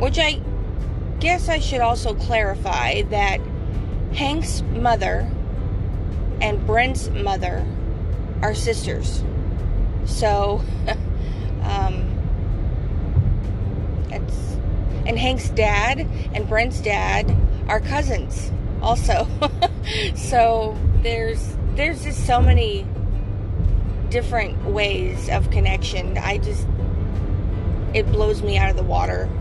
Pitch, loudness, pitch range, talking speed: 95 Hz, -22 LUFS, 90-100 Hz, 95 wpm